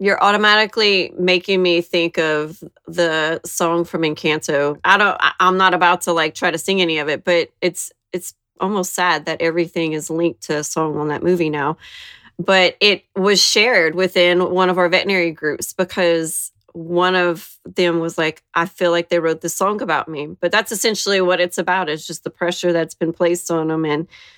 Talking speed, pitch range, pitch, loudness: 195 wpm, 160-185 Hz, 175 Hz, -17 LUFS